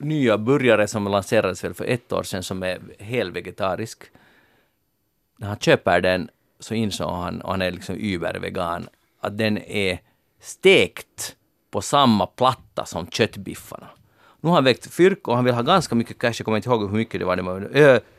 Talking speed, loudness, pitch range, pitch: 185 wpm, -21 LUFS, 95-120 Hz, 110 Hz